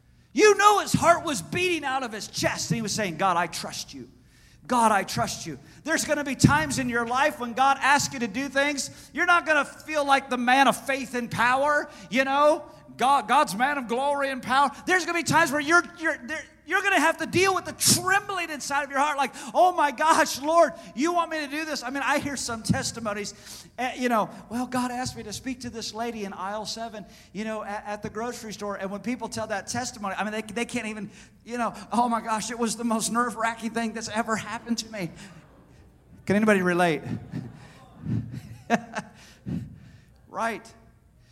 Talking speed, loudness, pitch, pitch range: 215 wpm, -25 LUFS, 245 Hz, 215-290 Hz